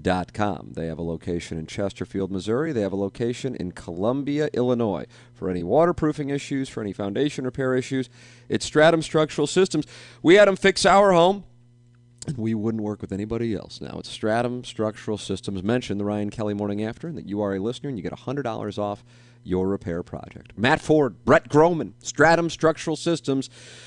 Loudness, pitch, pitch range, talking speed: -23 LUFS, 120 Hz, 100-145 Hz, 185 wpm